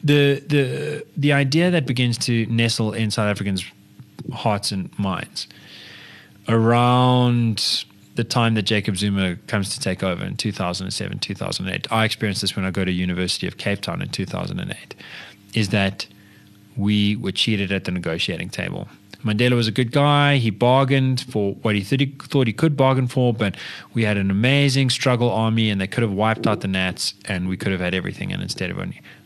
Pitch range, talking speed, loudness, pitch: 100-130 Hz, 205 wpm, -21 LUFS, 110 Hz